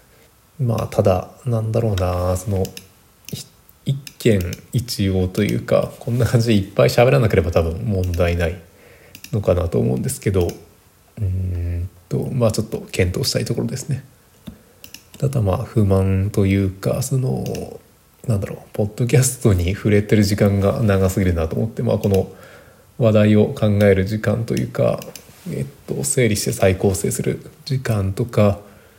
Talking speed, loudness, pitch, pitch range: 300 characters per minute, -19 LUFS, 100 Hz, 95-115 Hz